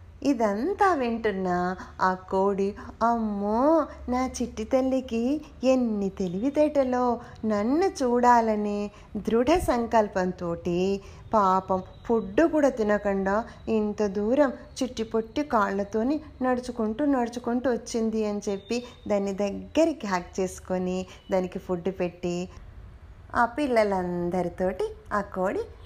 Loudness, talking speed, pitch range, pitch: -26 LUFS, 90 wpm, 190-255 Hz, 220 Hz